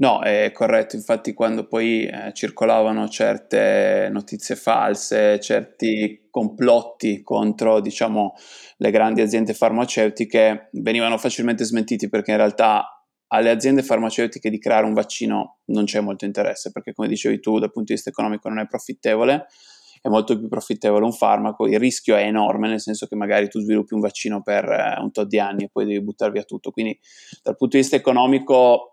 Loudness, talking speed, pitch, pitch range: -20 LUFS, 175 wpm, 110 Hz, 105-115 Hz